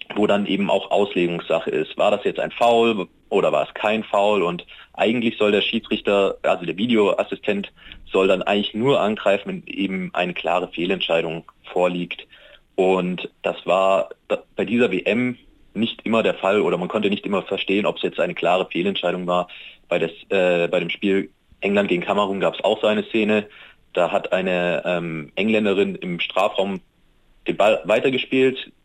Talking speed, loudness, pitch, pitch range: 175 wpm, -21 LUFS, 100 Hz, 90-105 Hz